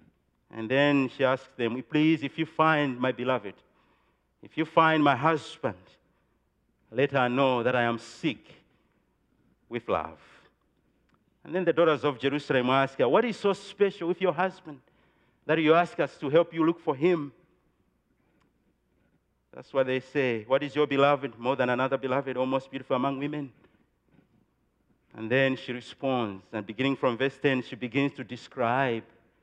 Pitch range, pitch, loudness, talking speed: 125-155 Hz, 135 Hz, -27 LUFS, 165 wpm